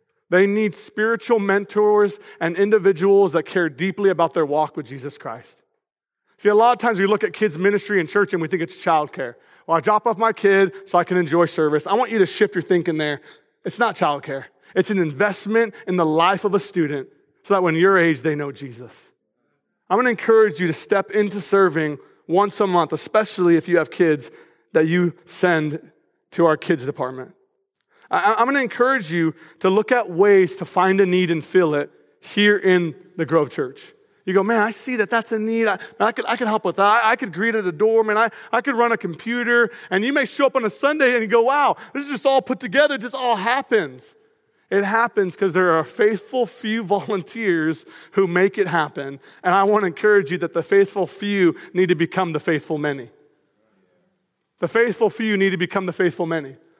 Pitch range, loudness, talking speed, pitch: 170-225 Hz, -19 LUFS, 215 wpm, 195 Hz